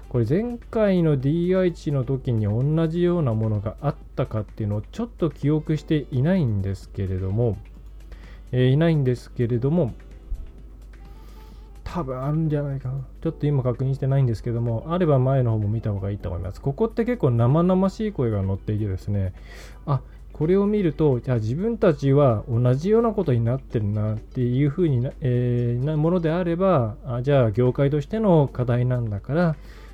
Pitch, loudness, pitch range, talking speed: 130 Hz, -23 LUFS, 110-160 Hz, 365 characters per minute